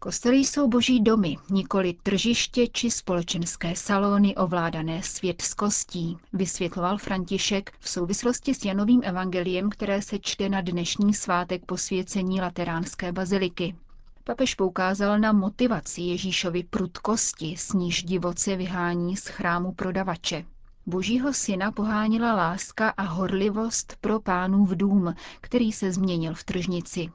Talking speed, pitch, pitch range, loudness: 120 wpm, 190 Hz, 180-210 Hz, -26 LUFS